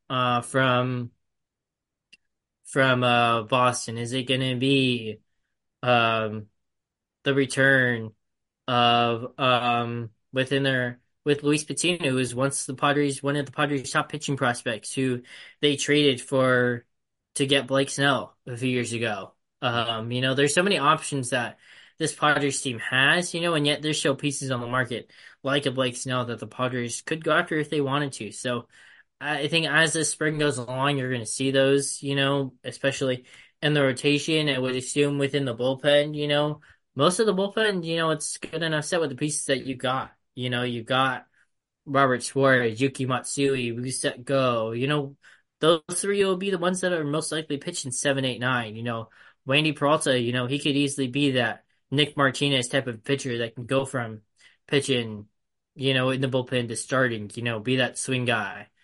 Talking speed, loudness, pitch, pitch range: 190 wpm, -24 LUFS, 135 Hz, 125-145 Hz